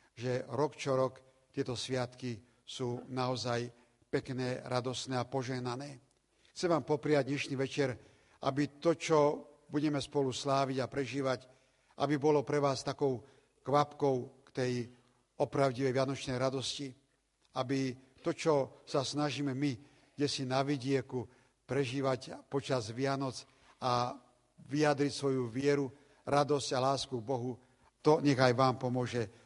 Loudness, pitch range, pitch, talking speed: -34 LUFS, 125-140 Hz, 135 Hz, 125 wpm